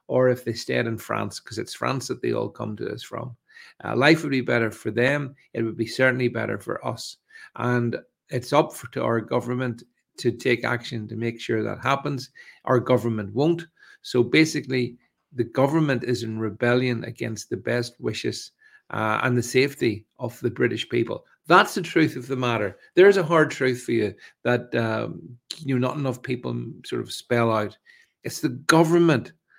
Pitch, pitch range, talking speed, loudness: 125 Hz, 115-140 Hz, 190 wpm, -24 LUFS